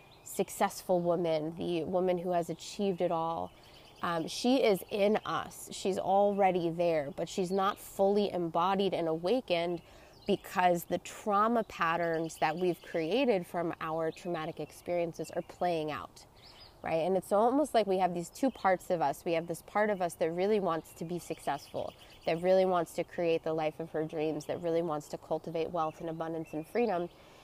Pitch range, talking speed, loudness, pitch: 165-190 Hz, 180 wpm, -32 LUFS, 175 Hz